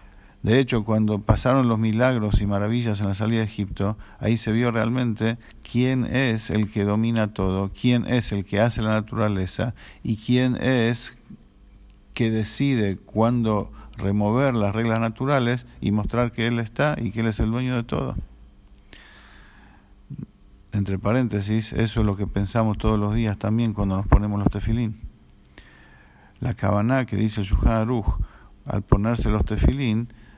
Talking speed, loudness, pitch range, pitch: 155 wpm, -23 LUFS, 100-120 Hz, 110 Hz